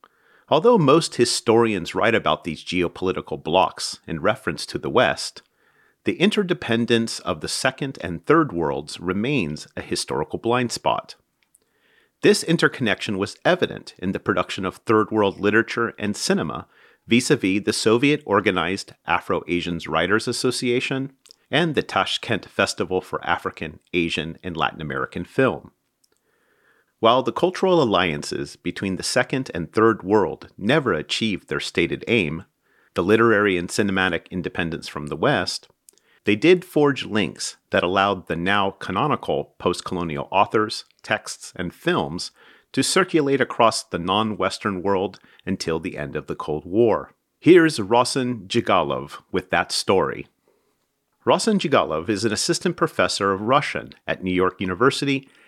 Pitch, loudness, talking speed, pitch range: 110 Hz, -22 LUFS, 135 wpm, 90-135 Hz